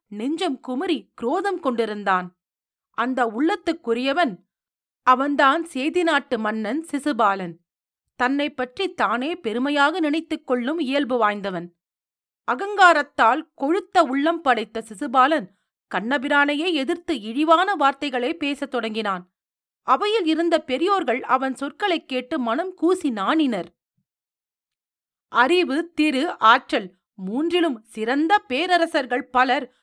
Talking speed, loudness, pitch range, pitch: 80 wpm, -21 LUFS, 240-325 Hz, 280 Hz